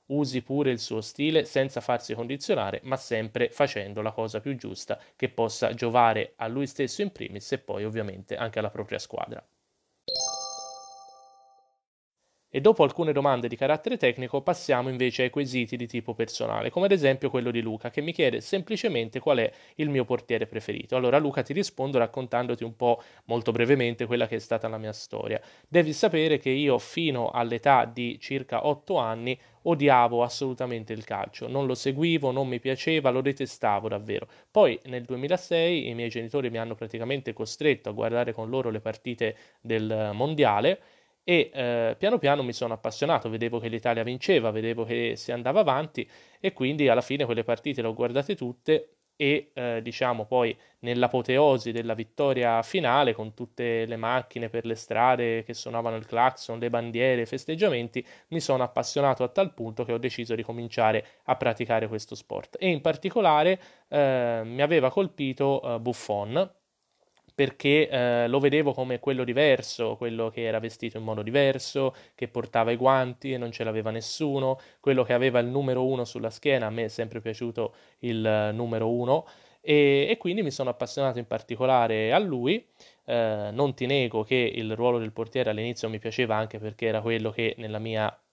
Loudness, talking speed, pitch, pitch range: -27 LUFS, 175 wpm, 125 Hz, 115-140 Hz